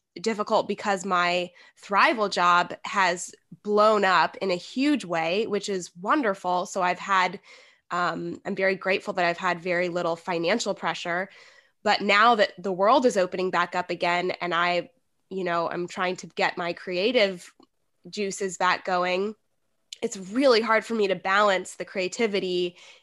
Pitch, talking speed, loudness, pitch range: 185 Hz, 160 wpm, -25 LUFS, 175-205 Hz